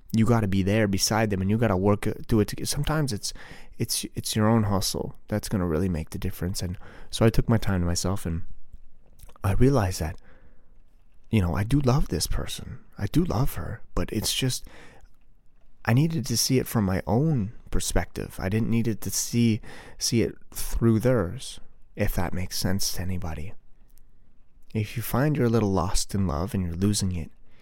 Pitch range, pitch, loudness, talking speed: 95-115 Hz, 105 Hz, -26 LUFS, 200 wpm